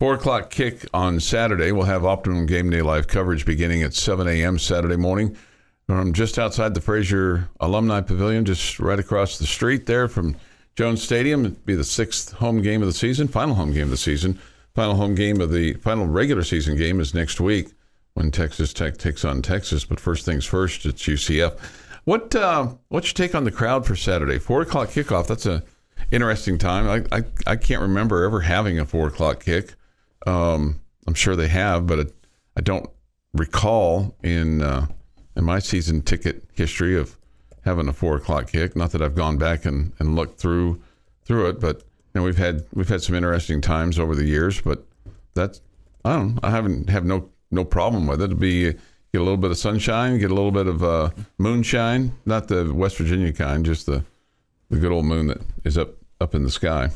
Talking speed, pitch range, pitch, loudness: 205 wpm, 80-105 Hz, 90 Hz, -22 LUFS